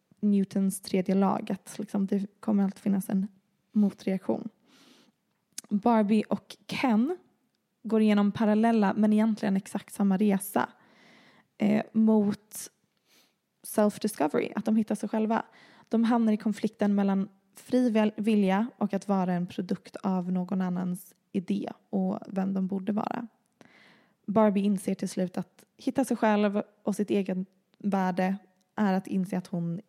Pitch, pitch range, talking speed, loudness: 205 Hz, 195-220 Hz, 135 wpm, -28 LUFS